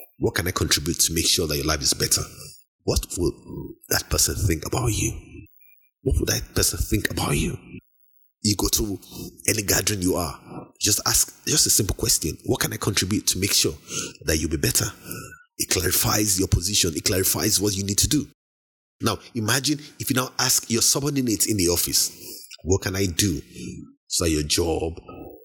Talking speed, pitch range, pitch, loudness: 185 wpm, 90-125 Hz, 105 Hz, -22 LUFS